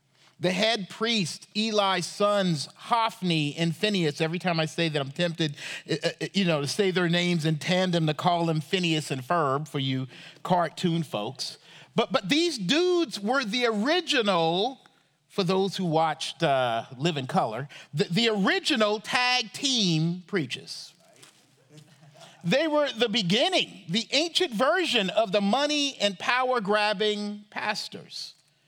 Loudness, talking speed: -26 LUFS, 140 wpm